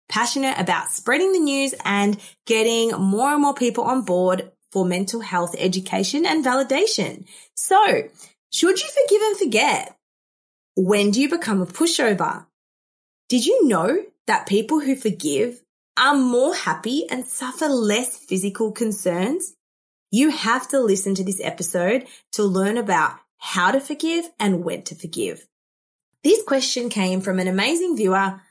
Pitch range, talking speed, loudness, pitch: 195-295 Hz, 145 wpm, -20 LUFS, 235 Hz